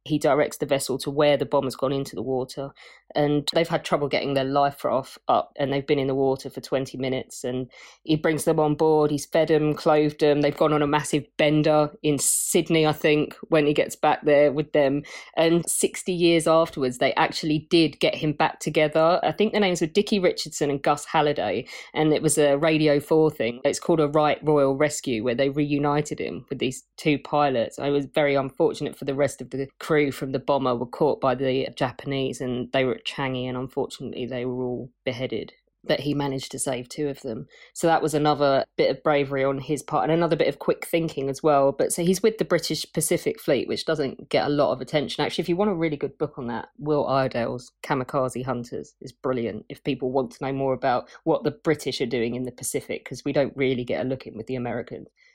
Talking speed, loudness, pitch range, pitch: 230 wpm, -24 LUFS, 135-155 Hz, 145 Hz